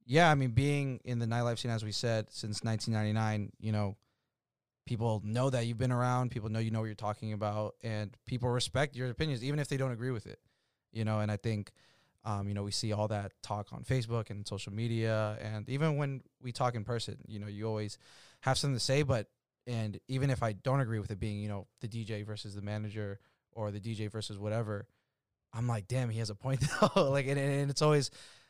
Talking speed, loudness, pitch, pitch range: 230 wpm, -34 LUFS, 115 Hz, 105-130 Hz